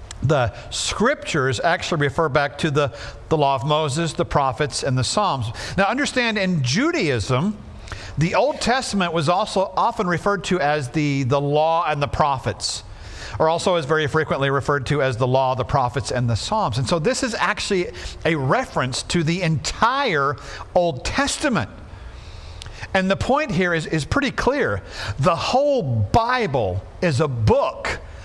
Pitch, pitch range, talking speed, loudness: 145 Hz, 115-175 Hz, 160 wpm, -21 LUFS